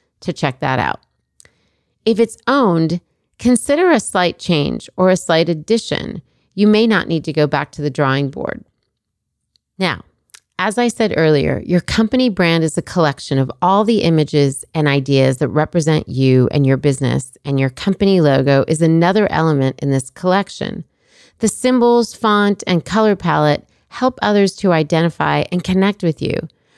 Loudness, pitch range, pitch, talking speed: -16 LUFS, 145-205 Hz, 165 Hz, 165 wpm